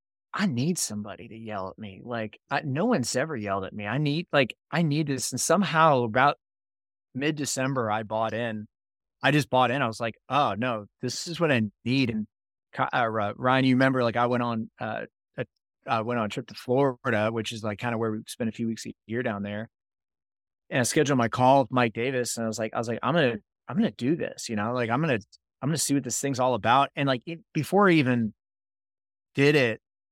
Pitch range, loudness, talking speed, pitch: 110-140 Hz, -26 LUFS, 235 wpm, 120 Hz